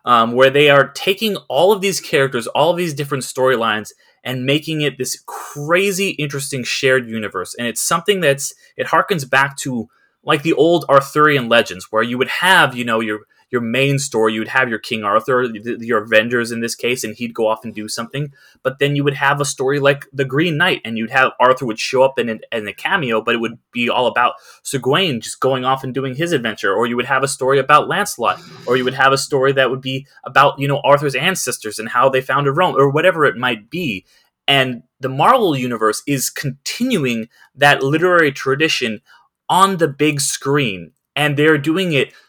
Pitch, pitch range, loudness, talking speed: 135 Hz, 120-145 Hz, -16 LUFS, 210 wpm